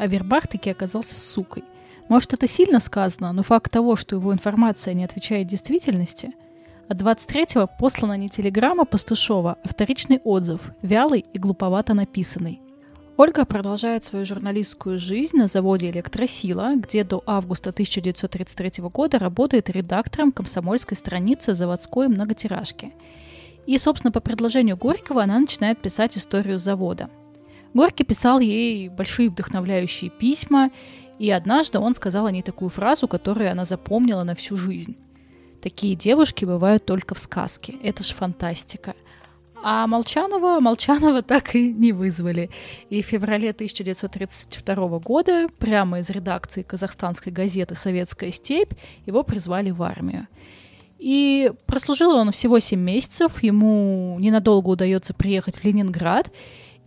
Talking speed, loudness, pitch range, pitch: 130 wpm, -21 LUFS, 185-245 Hz, 205 Hz